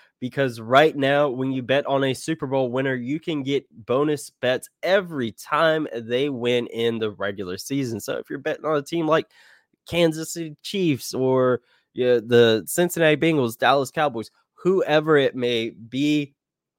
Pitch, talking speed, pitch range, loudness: 135 Hz, 170 wpm, 120-155 Hz, -22 LUFS